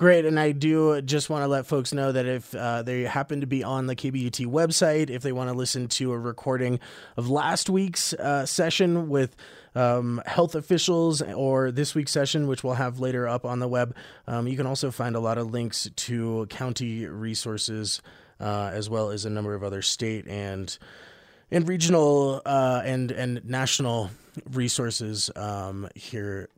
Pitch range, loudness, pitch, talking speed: 115-140 Hz, -26 LUFS, 125 Hz, 185 wpm